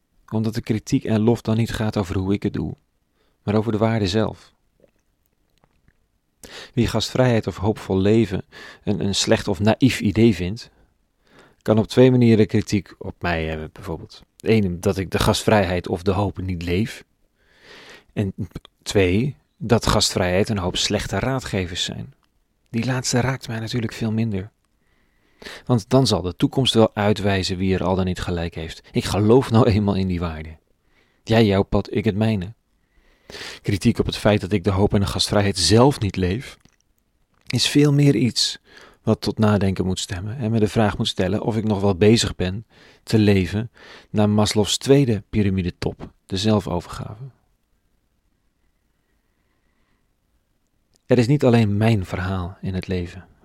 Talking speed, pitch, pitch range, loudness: 165 wpm, 105 Hz, 95-115 Hz, -20 LUFS